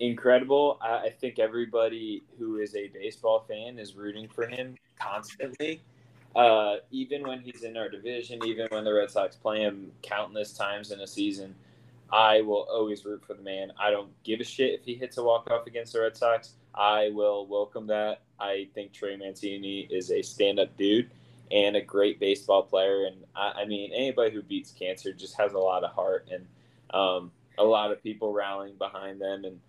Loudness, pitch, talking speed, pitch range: -28 LUFS, 110 Hz, 195 wpm, 100-125 Hz